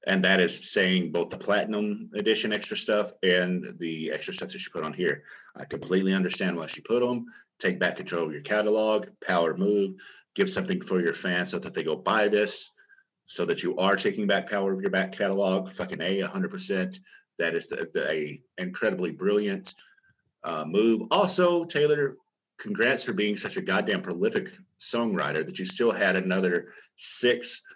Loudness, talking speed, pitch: -27 LUFS, 180 wpm, 105 Hz